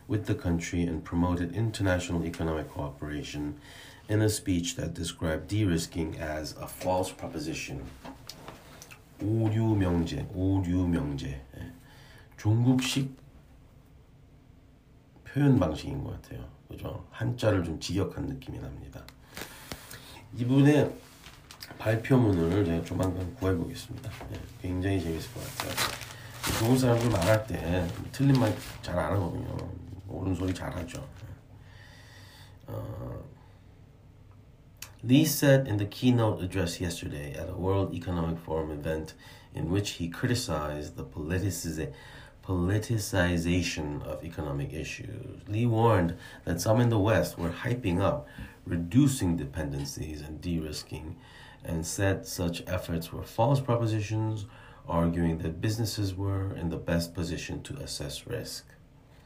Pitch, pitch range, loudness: 95 Hz, 85-120 Hz, -30 LUFS